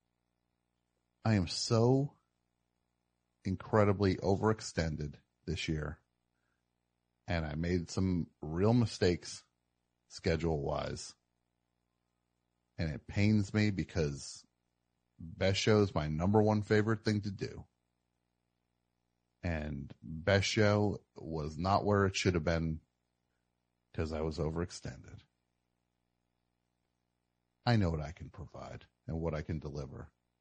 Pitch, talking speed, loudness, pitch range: 75 Hz, 110 wpm, -33 LUFS, 60-95 Hz